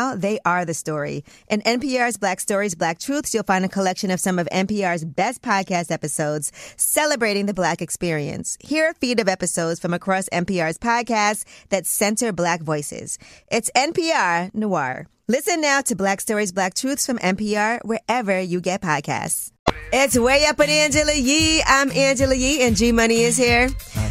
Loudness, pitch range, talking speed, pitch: -20 LUFS, 180-255 Hz, 170 wpm, 210 Hz